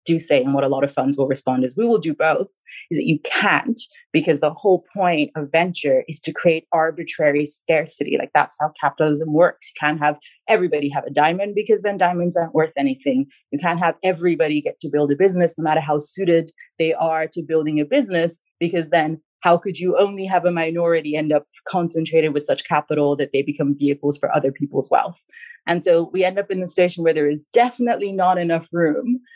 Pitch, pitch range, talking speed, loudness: 160 Hz, 150-180 Hz, 215 wpm, -20 LUFS